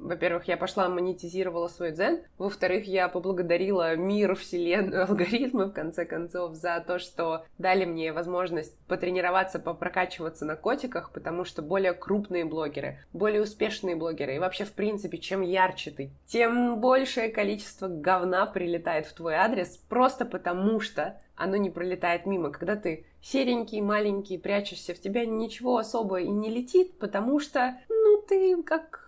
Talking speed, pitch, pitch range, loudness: 150 wpm, 185 Hz, 175-215 Hz, -28 LUFS